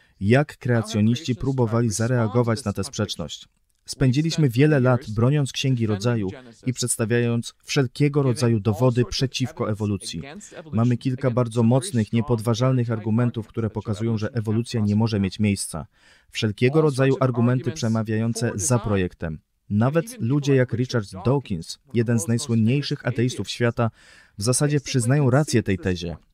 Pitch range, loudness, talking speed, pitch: 110-125 Hz, -23 LUFS, 130 wpm, 120 Hz